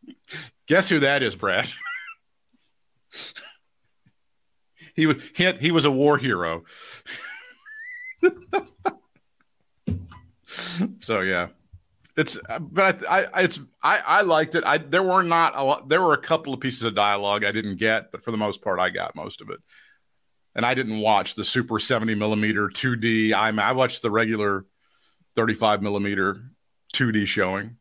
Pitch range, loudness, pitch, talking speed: 105-170 Hz, -22 LUFS, 125 Hz, 155 wpm